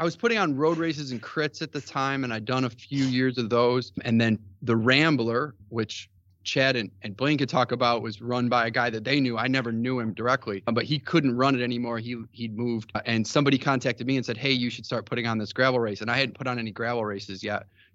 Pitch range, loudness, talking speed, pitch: 115-135 Hz, -26 LUFS, 255 wpm, 120 Hz